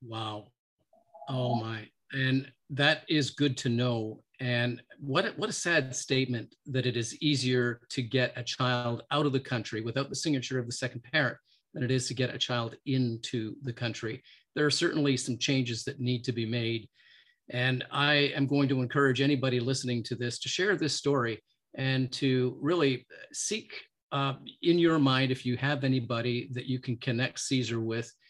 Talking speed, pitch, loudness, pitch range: 180 wpm, 130 Hz, -30 LUFS, 120-140 Hz